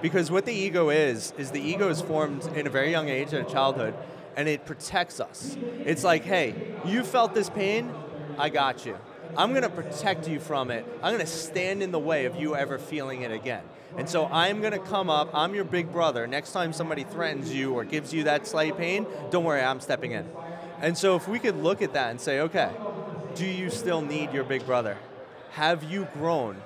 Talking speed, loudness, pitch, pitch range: 220 wpm, -28 LUFS, 160 Hz, 145-185 Hz